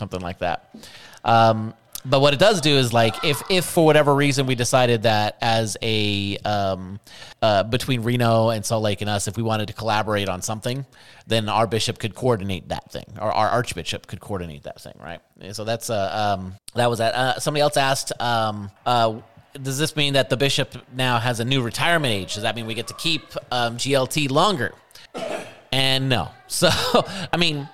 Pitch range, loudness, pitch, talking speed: 105-135 Hz, -21 LUFS, 115 Hz, 205 wpm